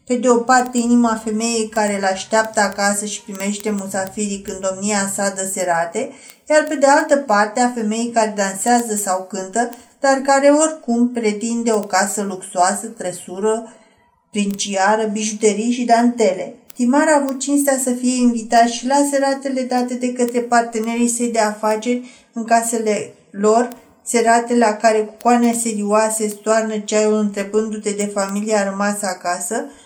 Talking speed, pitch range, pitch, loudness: 150 wpm, 205-240 Hz, 225 Hz, -18 LUFS